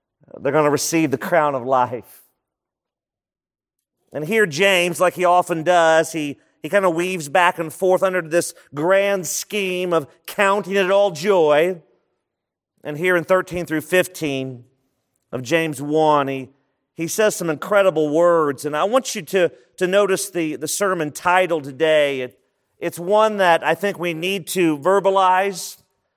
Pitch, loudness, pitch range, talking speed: 170 Hz, -19 LUFS, 150-190 Hz, 160 wpm